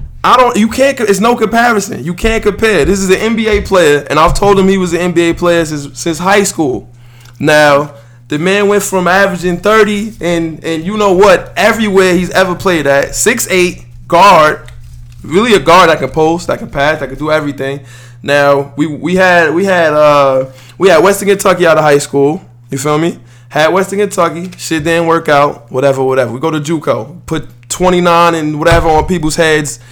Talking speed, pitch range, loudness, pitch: 195 wpm, 145-190 Hz, -10 LUFS, 165 Hz